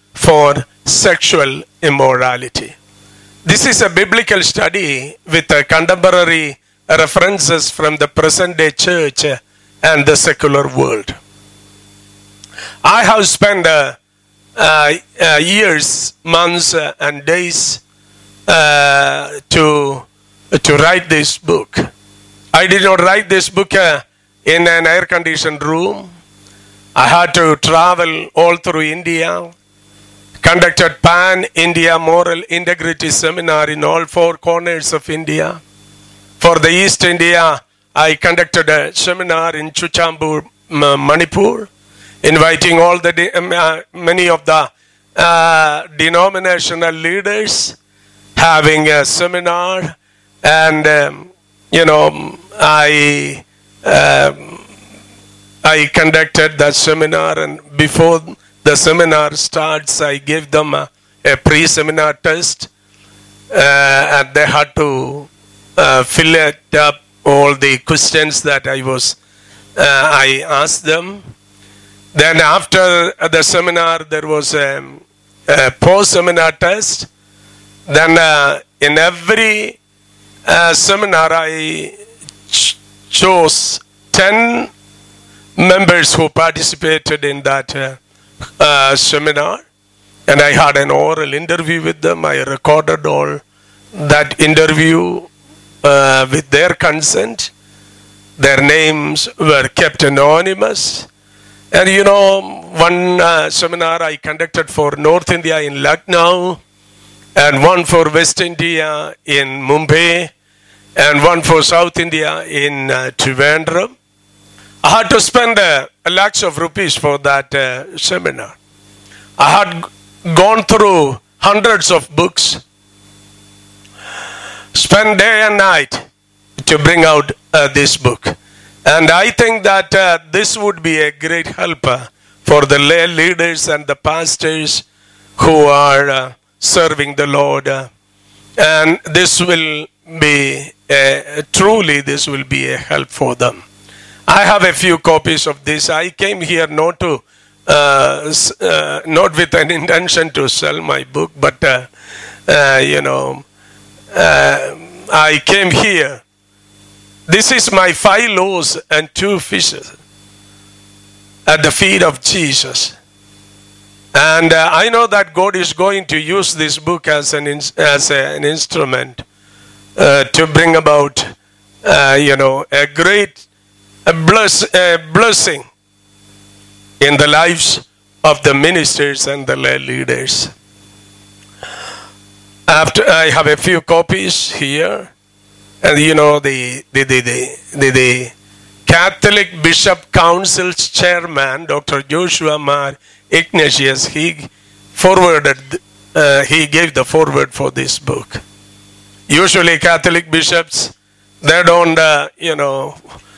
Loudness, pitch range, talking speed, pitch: -10 LUFS, 125-170 Hz, 120 wpm, 150 Hz